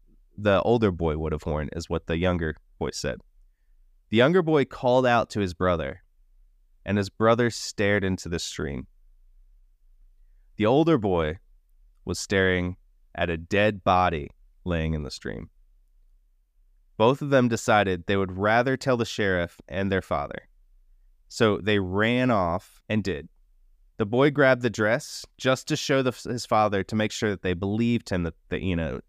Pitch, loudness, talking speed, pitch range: 95 Hz, -25 LUFS, 170 wpm, 85-115 Hz